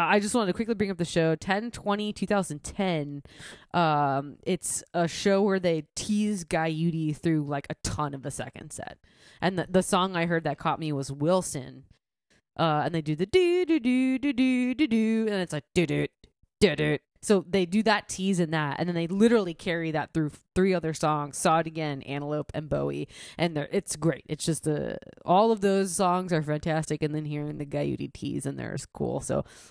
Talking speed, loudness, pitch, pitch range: 215 wpm, -27 LUFS, 165 Hz, 150-195 Hz